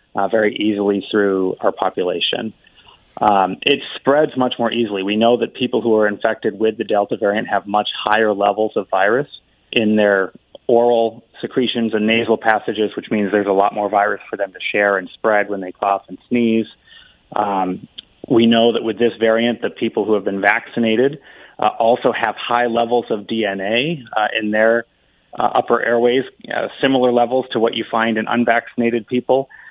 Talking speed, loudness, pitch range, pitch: 180 wpm, -17 LUFS, 105-120 Hz, 110 Hz